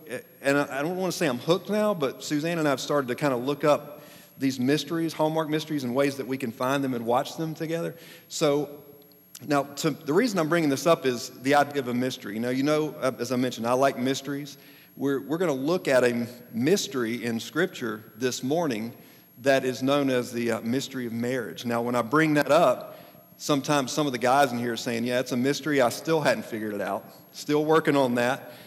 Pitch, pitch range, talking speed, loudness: 140 Hz, 125-150 Hz, 225 wpm, -26 LUFS